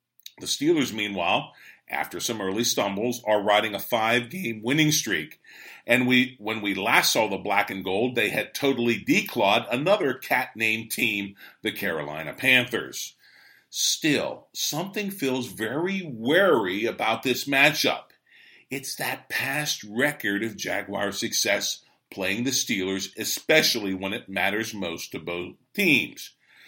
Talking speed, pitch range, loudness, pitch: 135 wpm, 100-130 Hz, -24 LUFS, 115 Hz